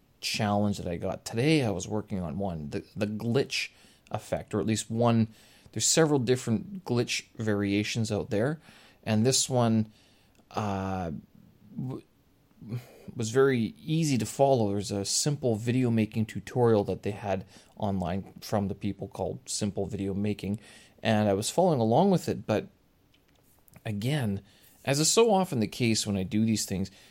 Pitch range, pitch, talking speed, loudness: 100-120 Hz, 110 Hz, 160 wpm, -28 LUFS